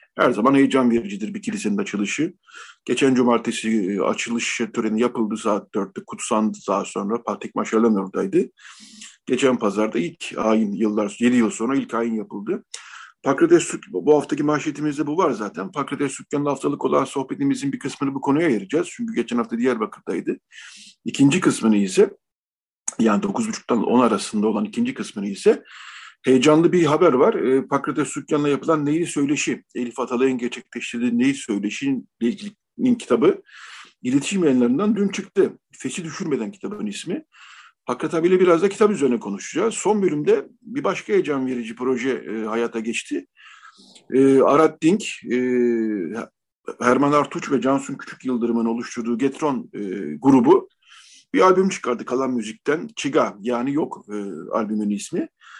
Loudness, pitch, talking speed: -21 LUFS, 140 Hz, 140 wpm